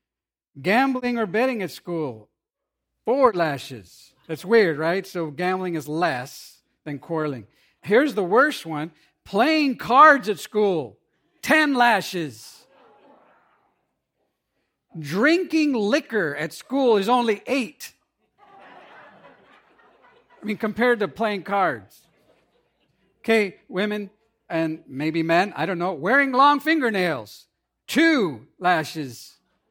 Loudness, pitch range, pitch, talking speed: -22 LUFS, 160-240 Hz, 190 Hz, 105 wpm